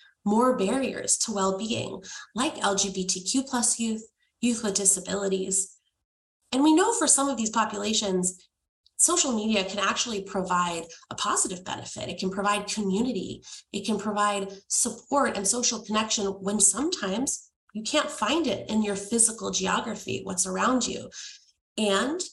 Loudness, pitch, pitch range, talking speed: -25 LUFS, 215 Hz, 195-245 Hz, 140 wpm